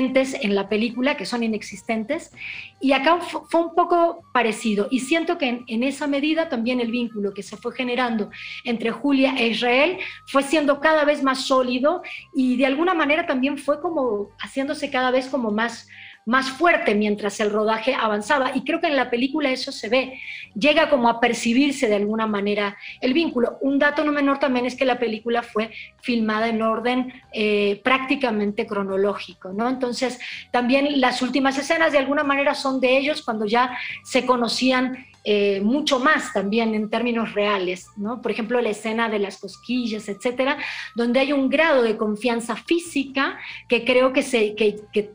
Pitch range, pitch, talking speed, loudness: 220-280 Hz, 250 Hz, 175 wpm, -21 LUFS